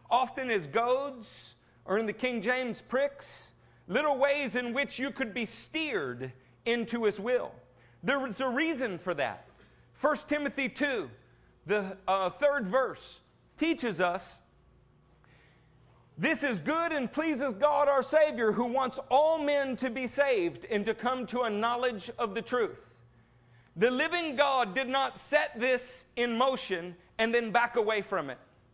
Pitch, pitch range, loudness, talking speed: 250 Hz, 210-280 Hz, -30 LUFS, 155 wpm